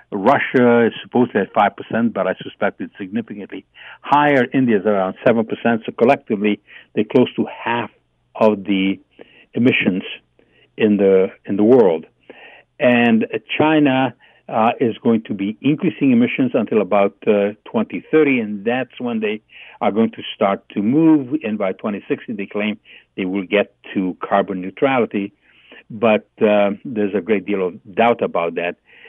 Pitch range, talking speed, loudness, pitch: 100-150 Hz, 155 wpm, -18 LUFS, 115 Hz